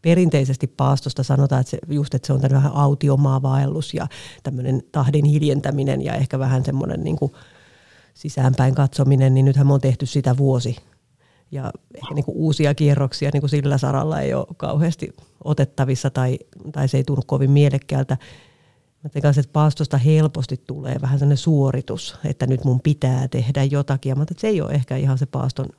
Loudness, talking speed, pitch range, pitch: -20 LUFS, 175 wpm, 135-145 Hz, 140 Hz